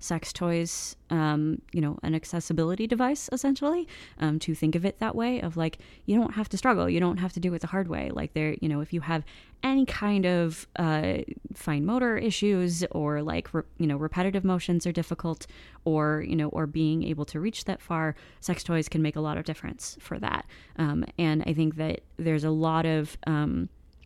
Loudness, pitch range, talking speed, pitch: -28 LUFS, 155-190 Hz, 210 wpm, 165 Hz